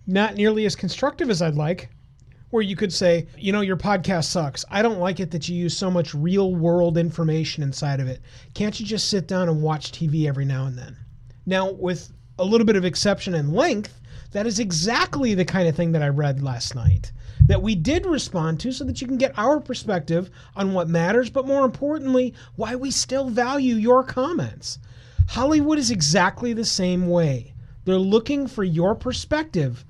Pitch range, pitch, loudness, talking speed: 150-225 Hz, 180 Hz, -22 LUFS, 200 wpm